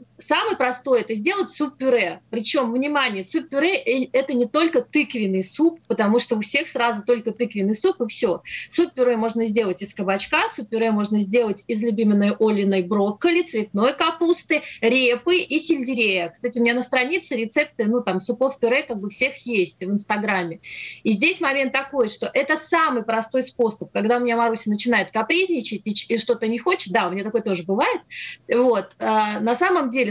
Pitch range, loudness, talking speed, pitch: 215-275 Hz, -21 LUFS, 180 wpm, 240 Hz